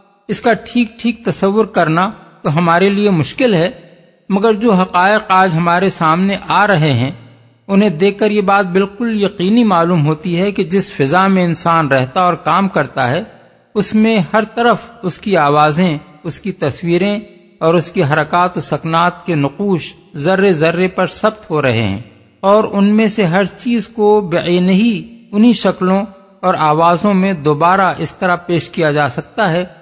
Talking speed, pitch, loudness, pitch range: 175 wpm, 185 Hz, -13 LUFS, 165-205 Hz